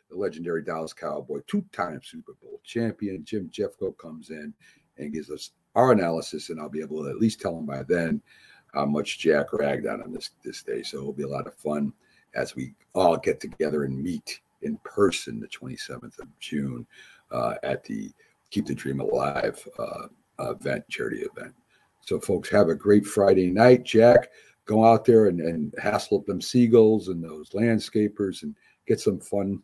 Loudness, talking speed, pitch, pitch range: -25 LUFS, 185 wpm, 95 Hz, 75-115 Hz